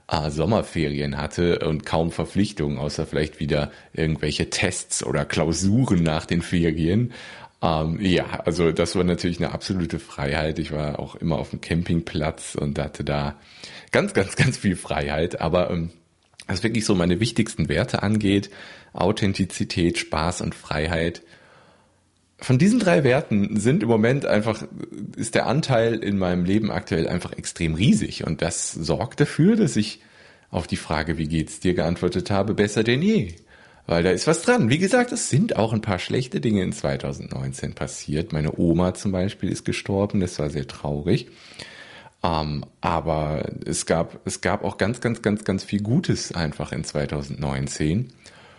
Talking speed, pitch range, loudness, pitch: 160 wpm, 80-105 Hz, -23 LUFS, 90 Hz